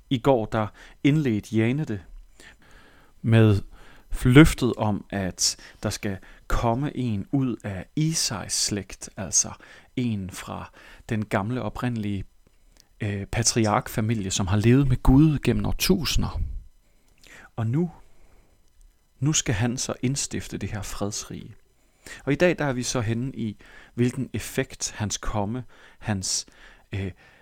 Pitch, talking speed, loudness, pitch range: 115 Hz, 125 wpm, -25 LUFS, 100-130 Hz